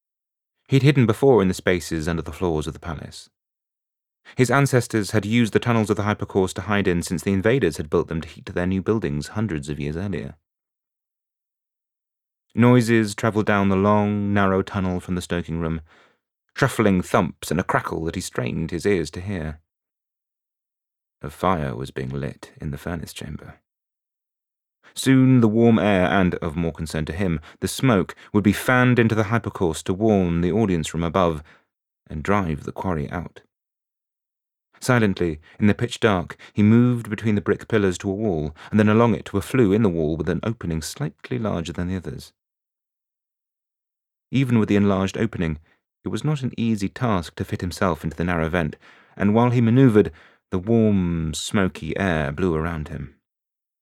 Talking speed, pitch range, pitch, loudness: 175 wpm, 85-110 Hz, 95 Hz, -22 LUFS